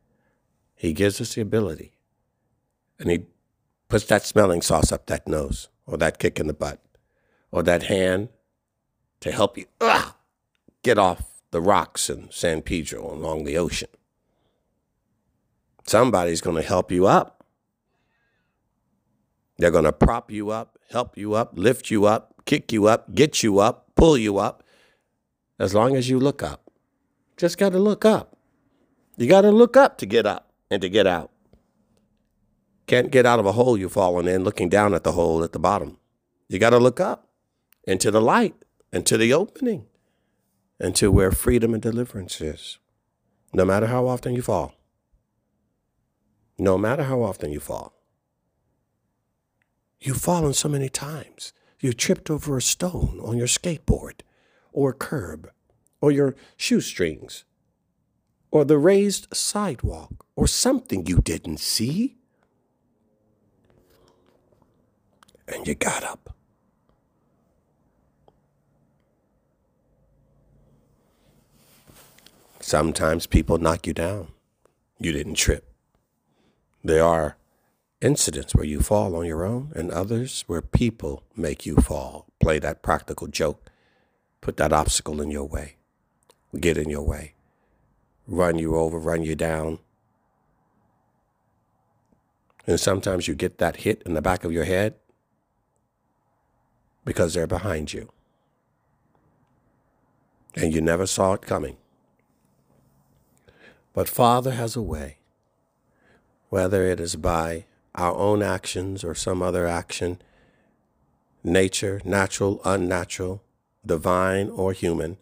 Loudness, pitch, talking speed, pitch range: -22 LUFS, 95 Hz, 130 wpm, 85-120 Hz